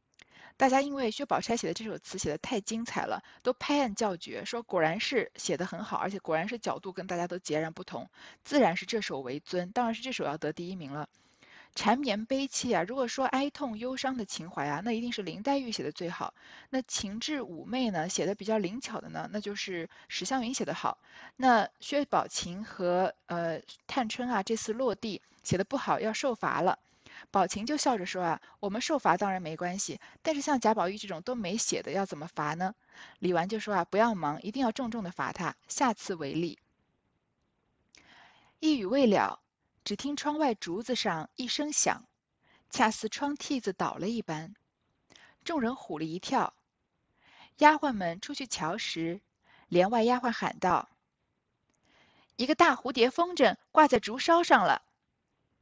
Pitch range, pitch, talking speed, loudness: 180-260 Hz, 220 Hz, 260 characters per minute, -31 LUFS